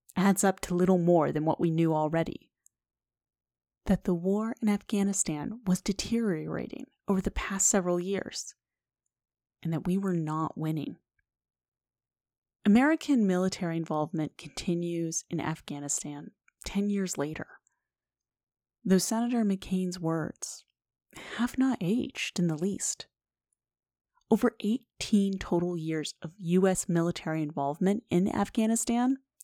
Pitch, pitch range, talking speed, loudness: 185 Hz, 165-205 Hz, 115 wpm, -29 LUFS